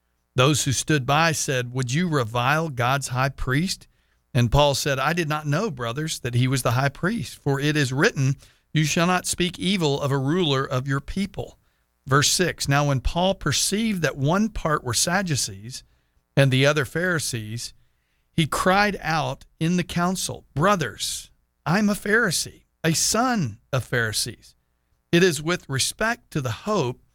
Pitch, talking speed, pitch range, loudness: 140 Hz, 170 wpm, 125-170 Hz, -23 LUFS